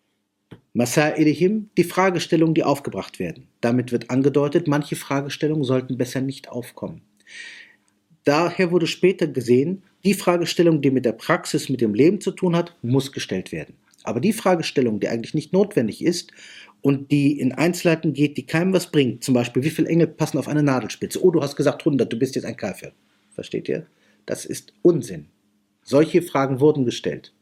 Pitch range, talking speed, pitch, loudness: 130-175 Hz, 175 wpm, 150 Hz, -21 LUFS